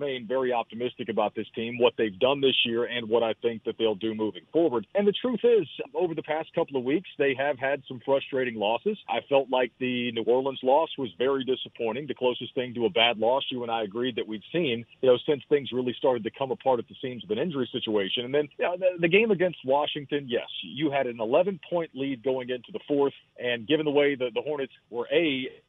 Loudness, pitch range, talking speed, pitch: -27 LUFS, 120-150 Hz, 245 wpm, 130 Hz